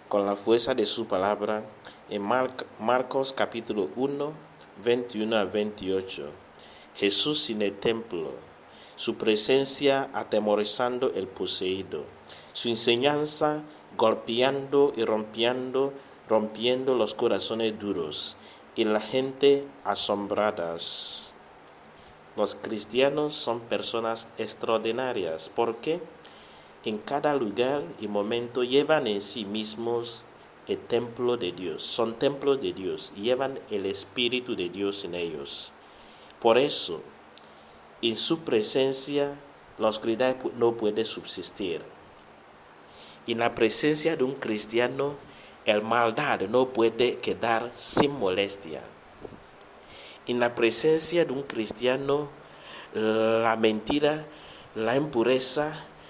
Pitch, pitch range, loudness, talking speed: 115 Hz, 110-135 Hz, -27 LUFS, 105 wpm